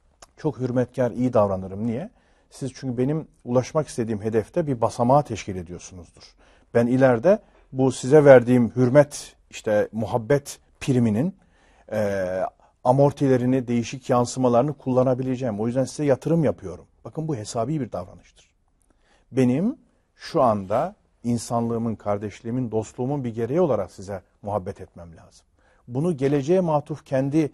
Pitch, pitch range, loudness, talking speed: 125 Hz, 105-140 Hz, -23 LUFS, 120 wpm